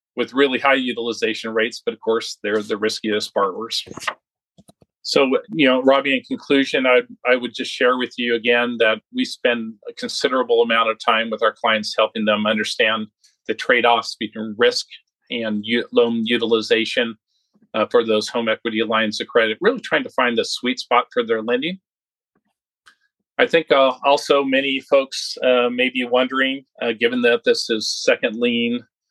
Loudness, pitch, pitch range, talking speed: -19 LUFS, 125 Hz, 115-140 Hz, 170 wpm